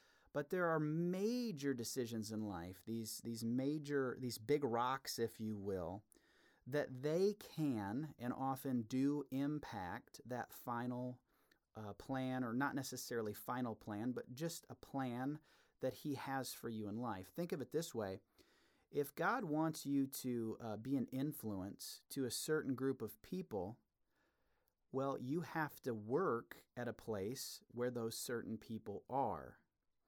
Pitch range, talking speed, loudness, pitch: 115-145 Hz, 150 wpm, -43 LUFS, 130 Hz